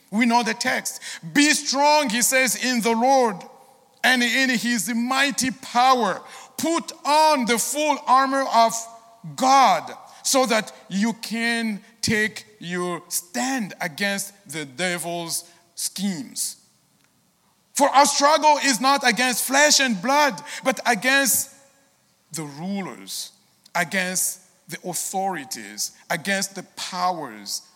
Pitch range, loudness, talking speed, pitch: 185-265 Hz, -21 LUFS, 115 wpm, 235 Hz